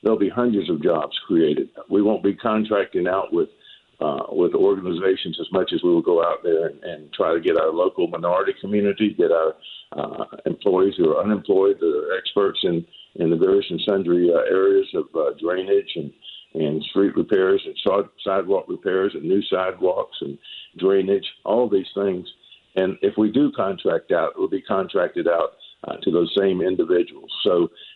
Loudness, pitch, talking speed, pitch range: -21 LUFS, 390 Hz, 185 wpm, 325-415 Hz